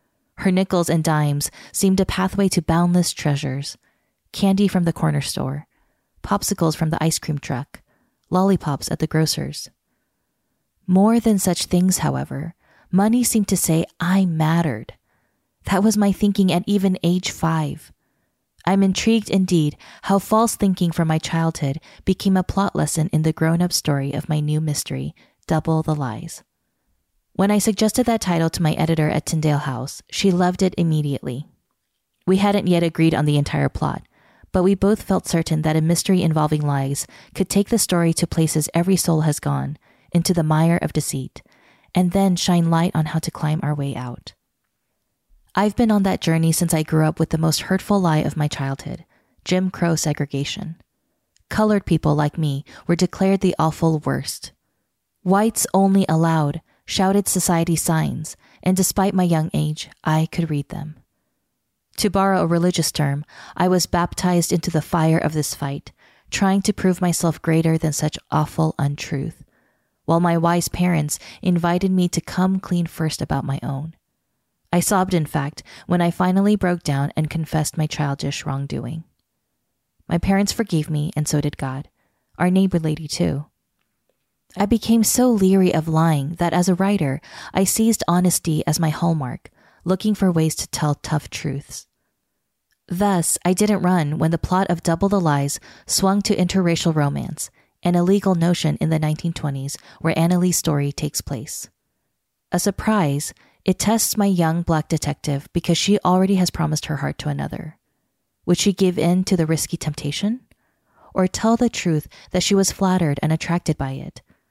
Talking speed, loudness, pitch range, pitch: 170 wpm, -20 LUFS, 155-190 Hz, 165 Hz